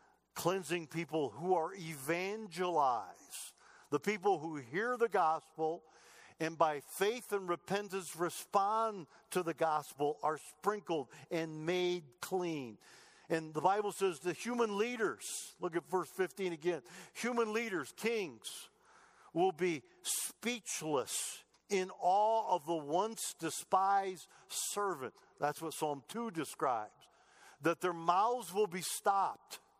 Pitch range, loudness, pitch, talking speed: 160-205 Hz, -37 LUFS, 180 Hz, 125 wpm